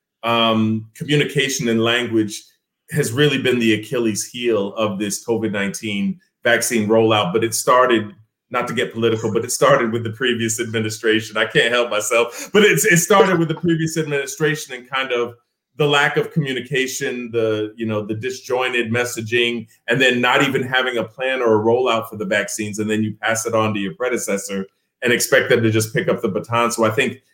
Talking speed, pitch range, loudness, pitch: 195 wpm, 110-130 Hz, -18 LUFS, 115 Hz